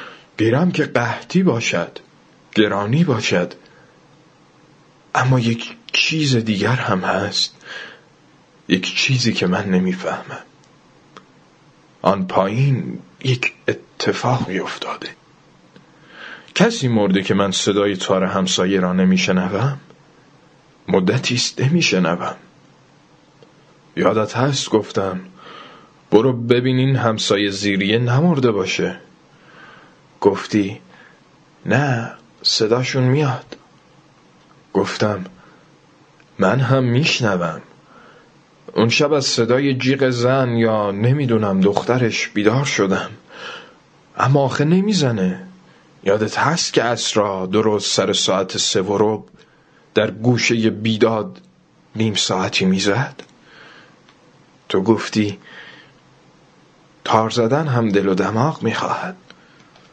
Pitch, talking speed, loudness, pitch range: 115 Hz, 90 wpm, -18 LUFS, 100-135 Hz